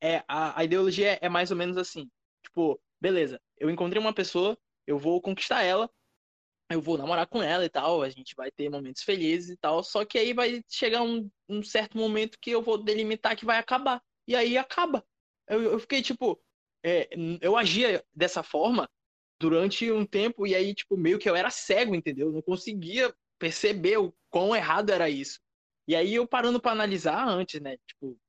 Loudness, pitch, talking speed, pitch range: -28 LUFS, 200 Hz, 195 wpm, 165-230 Hz